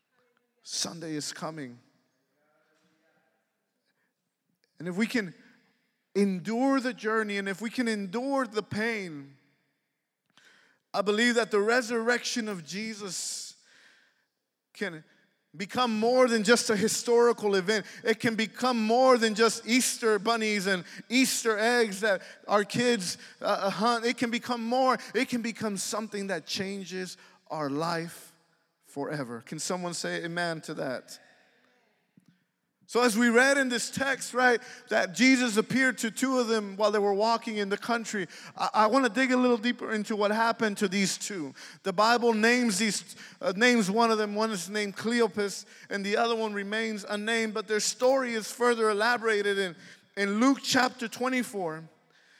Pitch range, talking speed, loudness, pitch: 195-240 Hz, 150 wpm, -27 LUFS, 220 Hz